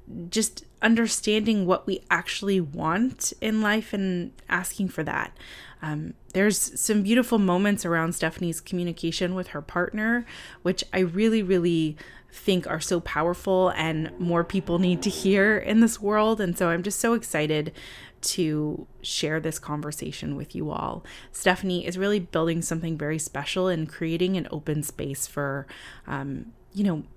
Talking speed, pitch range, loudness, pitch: 150 wpm, 160-200 Hz, -26 LUFS, 180 Hz